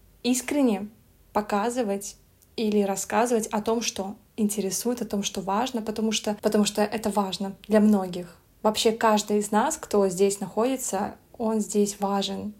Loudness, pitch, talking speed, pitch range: -25 LUFS, 210 Hz, 145 wpm, 200-225 Hz